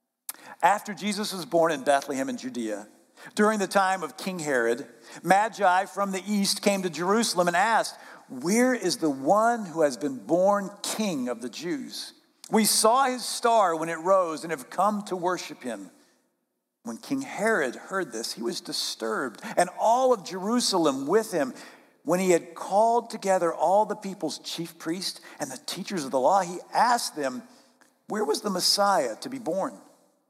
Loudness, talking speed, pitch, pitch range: -26 LUFS, 175 wpm, 200 Hz, 165-235 Hz